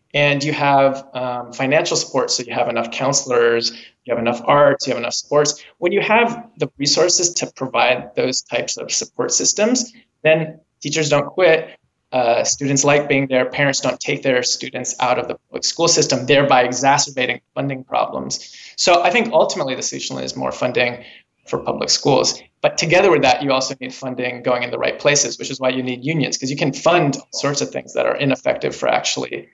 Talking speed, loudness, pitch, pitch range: 200 wpm, -18 LUFS, 140 Hz, 125-150 Hz